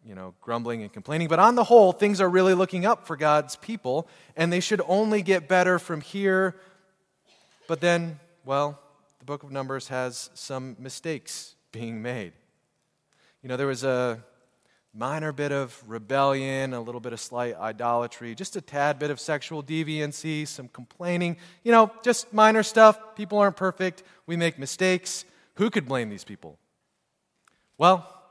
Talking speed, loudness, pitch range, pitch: 165 wpm, -24 LUFS, 130-185 Hz, 155 Hz